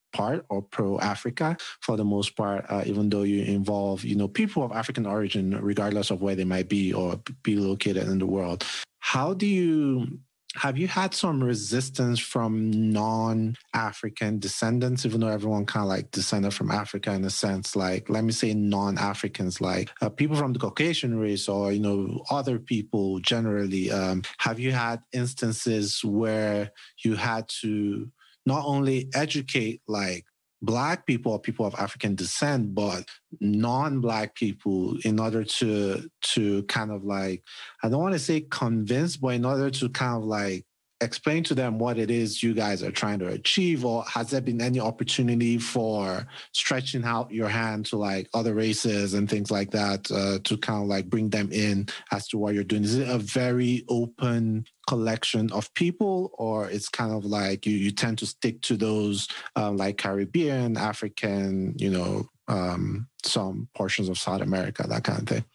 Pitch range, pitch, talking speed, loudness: 100-120 Hz, 110 Hz, 180 wpm, -27 LUFS